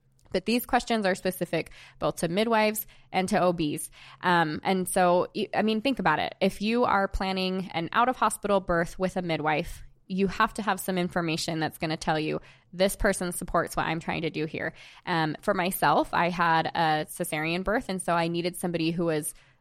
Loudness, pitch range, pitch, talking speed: -27 LUFS, 160-195 Hz, 180 Hz, 200 wpm